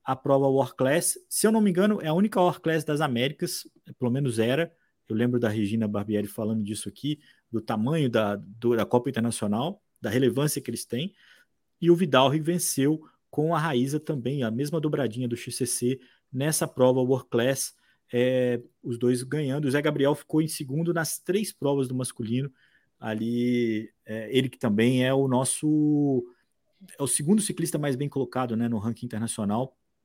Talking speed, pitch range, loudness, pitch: 180 wpm, 120-155 Hz, -26 LUFS, 135 Hz